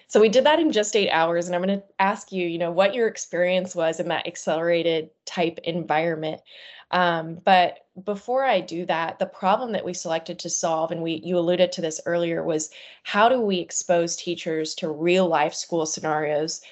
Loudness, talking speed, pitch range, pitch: -23 LUFS, 200 wpm, 165-185 Hz, 175 Hz